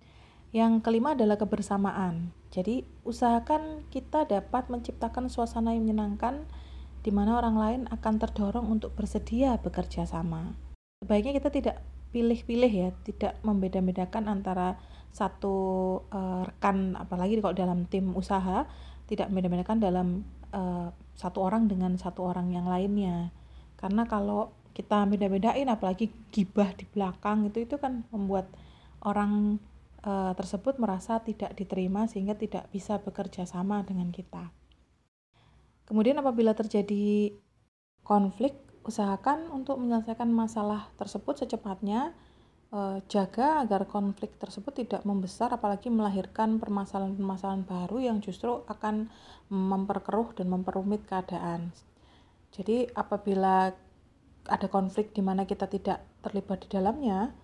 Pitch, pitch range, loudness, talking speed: 205 Hz, 190-225 Hz, -30 LUFS, 115 wpm